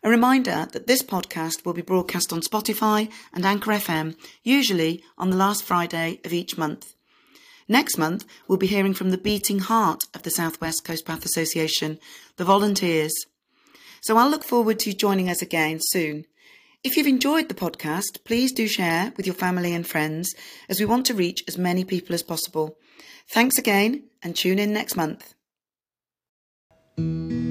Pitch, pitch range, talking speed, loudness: 185 Hz, 165-220 Hz, 170 wpm, -23 LUFS